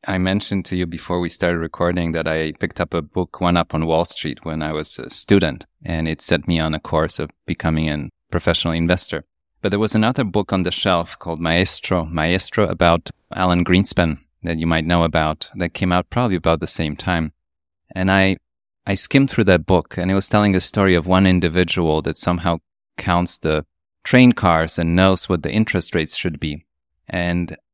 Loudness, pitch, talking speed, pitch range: -19 LUFS, 85 Hz, 205 wpm, 80-95 Hz